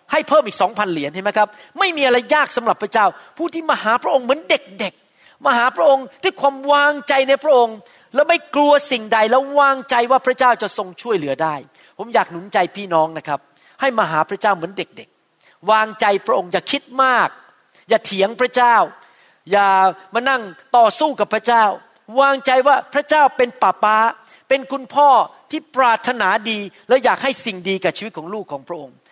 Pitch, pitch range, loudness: 235 Hz, 200-275 Hz, -17 LUFS